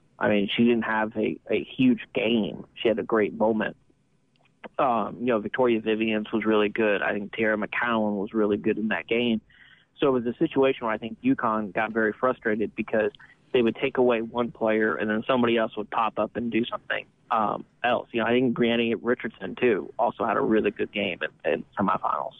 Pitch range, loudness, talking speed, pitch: 110-120 Hz, -25 LUFS, 210 wpm, 110 Hz